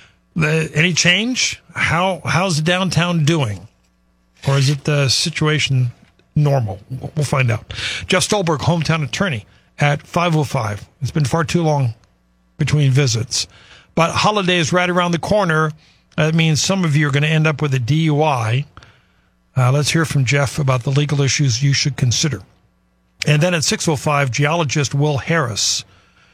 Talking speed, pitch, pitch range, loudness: 155 wpm, 145 Hz, 125-165 Hz, -17 LUFS